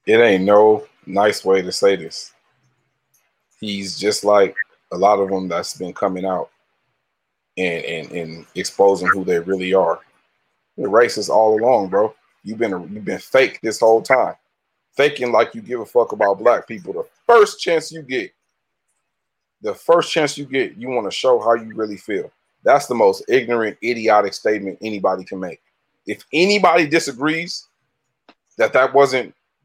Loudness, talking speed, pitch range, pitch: -18 LUFS, 170 wpm, 100-160 Hz, 110 Hz